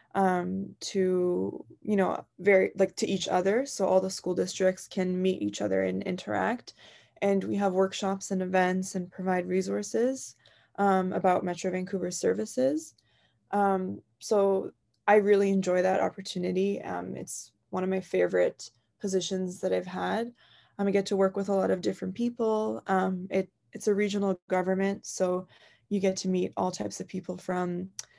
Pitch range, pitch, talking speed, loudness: 180-200 Hz, 190 Hz, 165 wpm, -29 LUFS